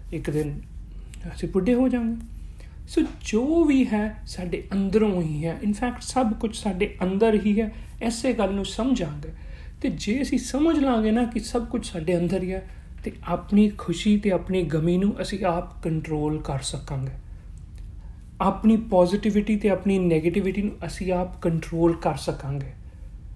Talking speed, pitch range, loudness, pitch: 155 wpm, 165-220 Hz, -24 LUFS, 190 Hz